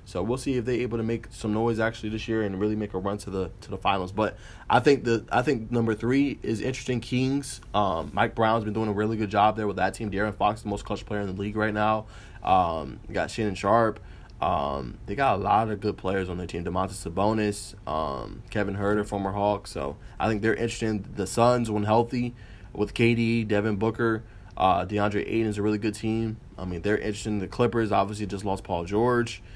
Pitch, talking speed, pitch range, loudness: 105 Hz, 230 wpm, 100-115 Hz, -27 LUFS